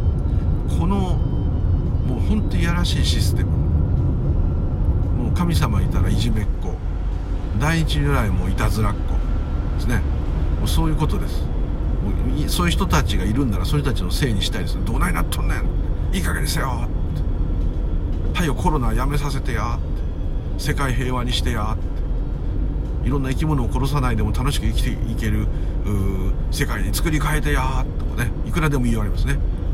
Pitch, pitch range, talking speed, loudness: 85 Hz, 75-95 Hz, 340 characters per minute, -22 LUFS